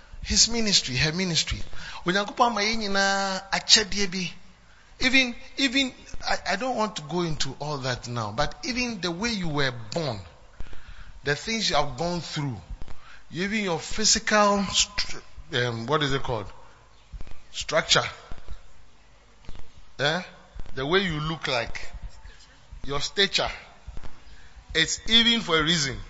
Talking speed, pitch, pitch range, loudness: 115 wpm, 170 Hz, 135-205 Hz, -24 LUFS